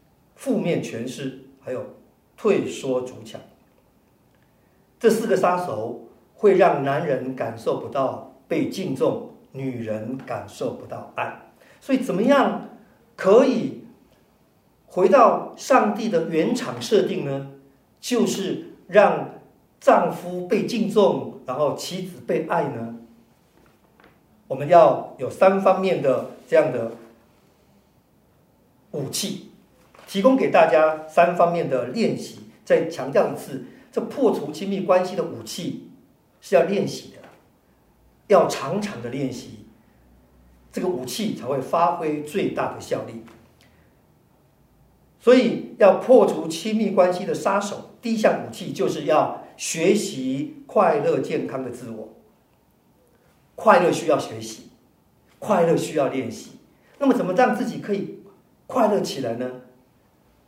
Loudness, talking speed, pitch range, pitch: -22 LUFS, 180 characters per minute, 130-215 Hz, 175 Hz